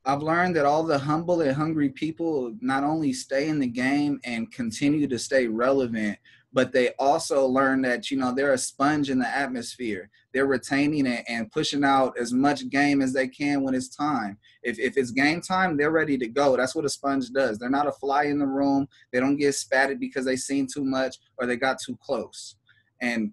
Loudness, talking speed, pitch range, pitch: -25 LUFS, 215 wpm, 130-145 Hz, 135 Hz